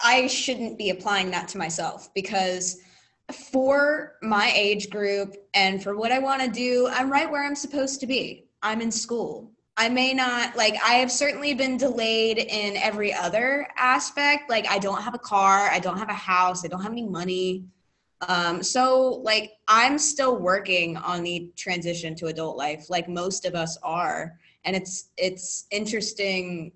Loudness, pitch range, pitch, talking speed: -24 LUFS, 185-255 Hz, 210 Hz, 175 wpm